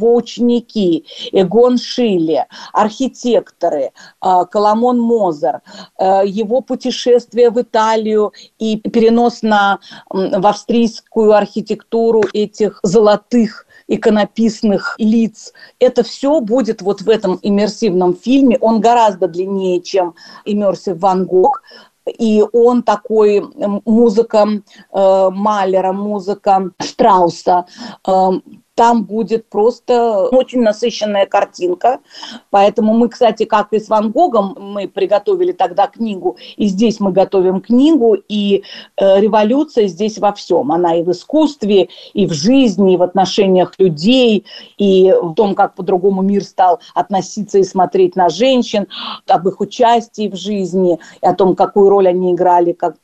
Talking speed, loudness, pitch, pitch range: 120 wpm, -13 LUFS, 210 Hz, 195-235 Hz